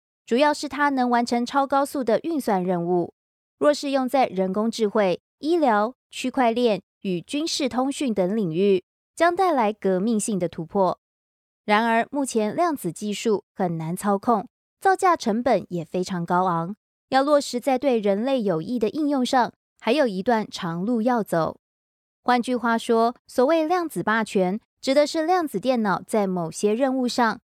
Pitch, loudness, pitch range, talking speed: 230 Hz, -23 LUFS, 190-270 Hz, 240 characters per minute